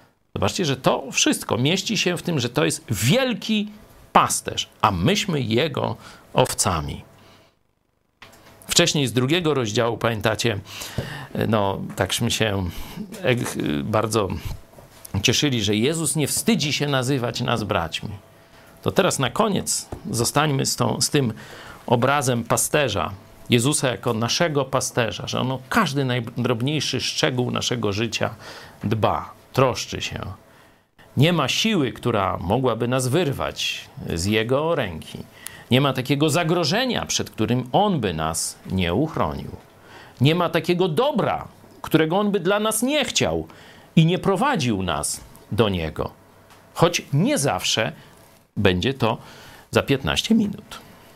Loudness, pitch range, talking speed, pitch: -22 LUFS, 110-160 Hz, 125 wpm, 130 Hz